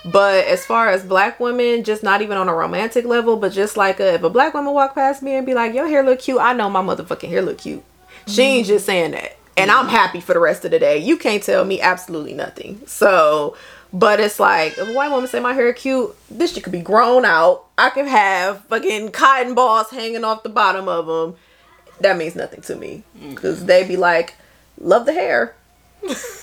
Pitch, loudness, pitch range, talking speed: 225 Hz, -16 LUFS, 190-255 Hz, 225 wpm